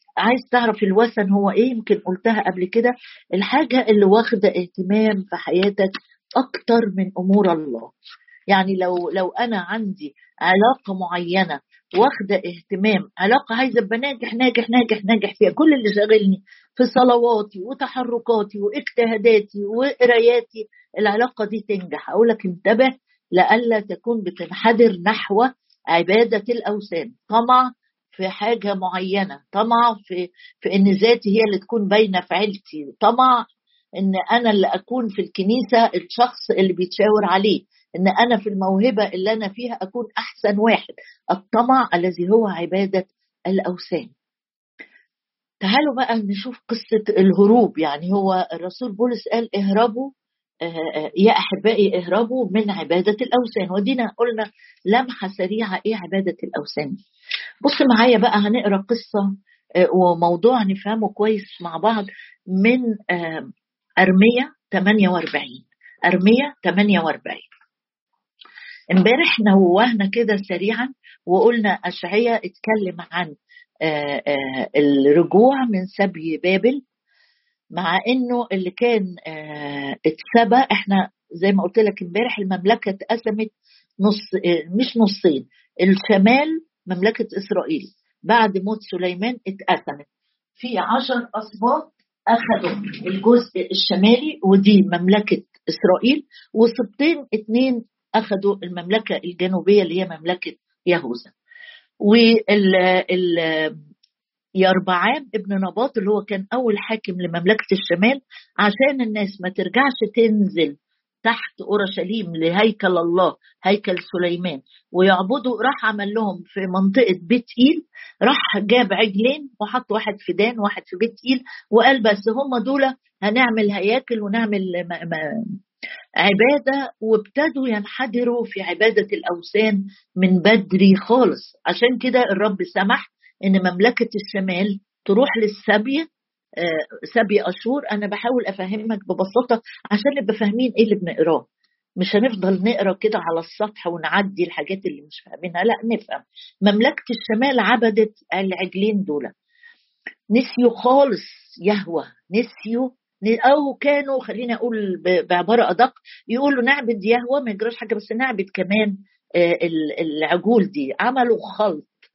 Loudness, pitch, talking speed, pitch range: -19 LUFS, 215 Hz, 115 wpm, 190-240 Hz